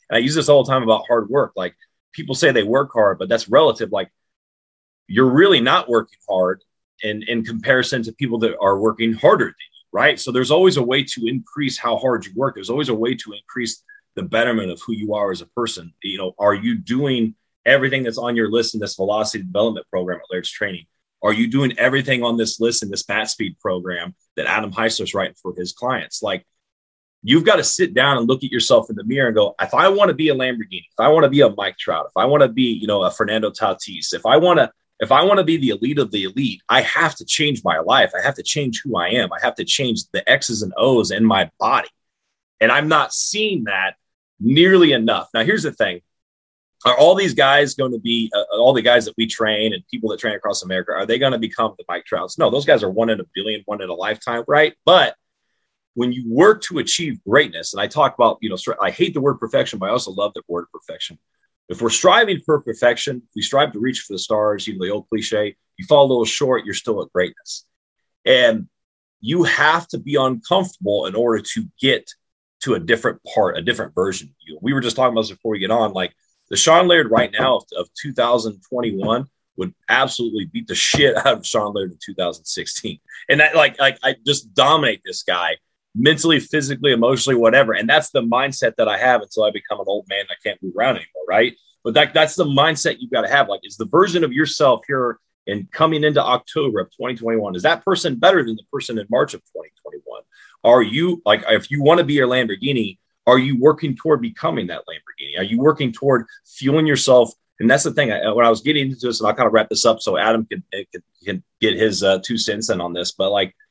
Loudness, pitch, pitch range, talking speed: -18 LUFS, 120 Hz, 110-145 Hz, 240 wpm